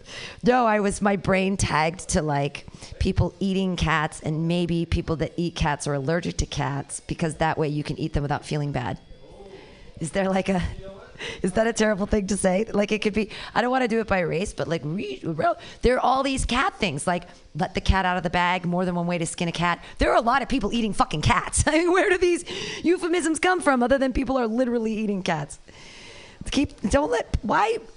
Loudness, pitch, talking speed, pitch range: -24 LUFS, 190 Hz, 225 wpm, 165-240 Hz